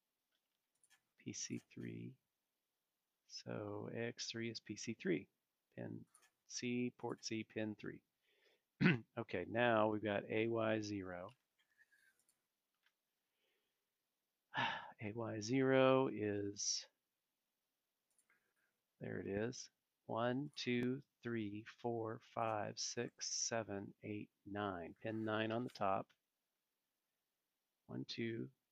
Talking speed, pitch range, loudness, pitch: 90 wpm, 105-125 Hz, -42 LUFS, 110 Hz